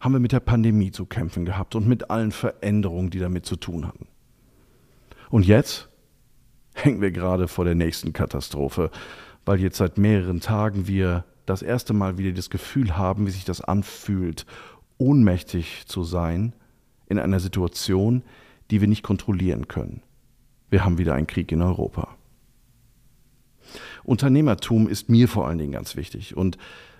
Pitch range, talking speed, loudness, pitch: 90-125 Hz, 155 wpm, -23 LUFS, 100 Hz